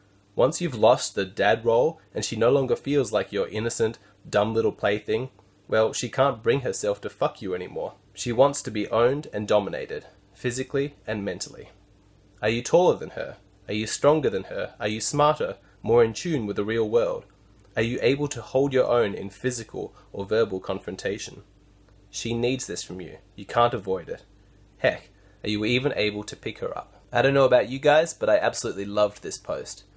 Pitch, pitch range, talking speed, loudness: 115 Hz, 105-135 Hz, 195 wpm, -25 LUFS